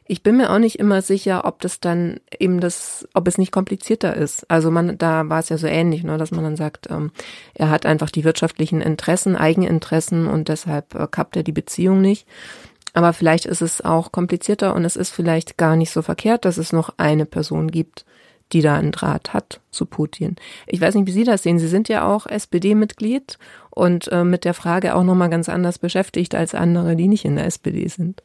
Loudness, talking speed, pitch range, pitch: -19 LUFS, 210 wpm, 160-190 Hz, 175 Hz